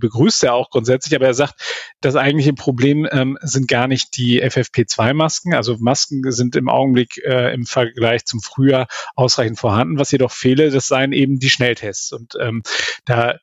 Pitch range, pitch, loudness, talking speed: 120-140 Hz, 130 Hz, -16 LUFS, 175 wpm